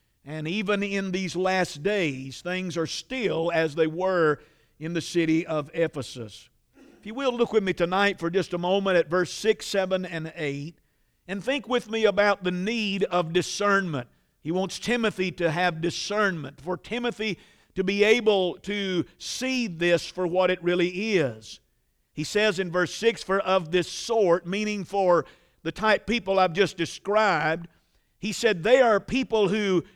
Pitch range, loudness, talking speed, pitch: 170-205 Hz, -25 LUFS, 170 wpm, 185 Hz